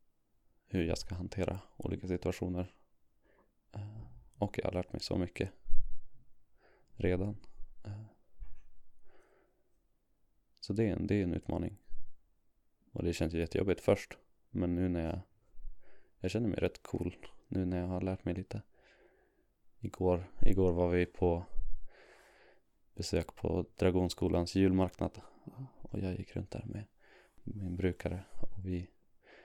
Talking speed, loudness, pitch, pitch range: 130 wpm, -36 LUFS, 90 Hz, 90-105 Hz